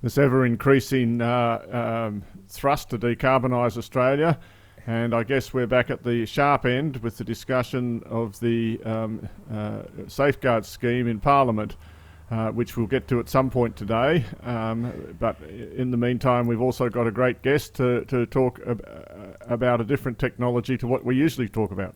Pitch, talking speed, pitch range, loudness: 120 Hz, 170 wpm, 115-130 Hz, -24 LUFS